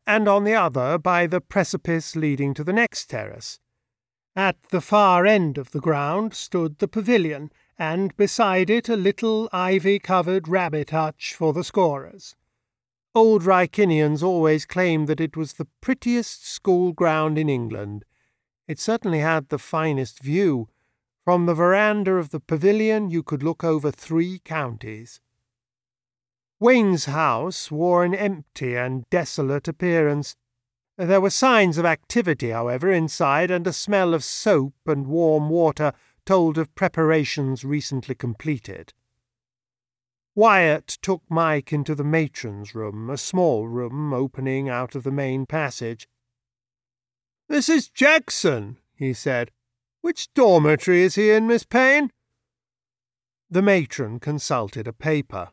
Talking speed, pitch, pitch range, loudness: 135 wpm, 155 Hz, 125-185 Hz, -21 LUFS